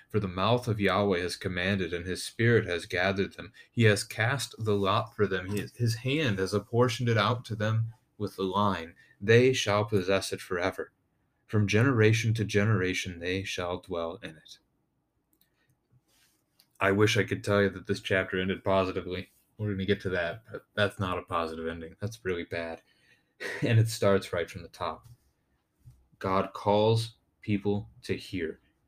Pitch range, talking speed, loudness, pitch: 95-110 Hz, 170 wpm, -29 LUFS, 100 Hz